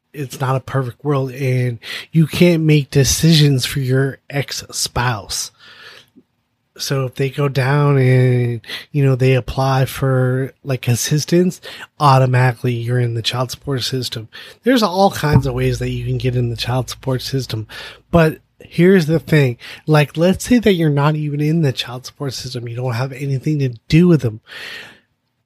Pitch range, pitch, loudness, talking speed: 125-150 Hz, 135 Hz, -17 LUFS, 170 wpm